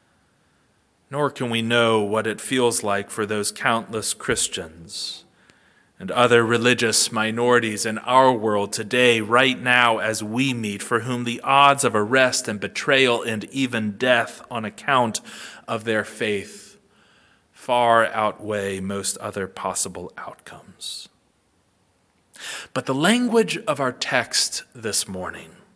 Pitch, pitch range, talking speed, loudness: 115 Hz, 105-125 Hz, 130 wpm, -21 LUFS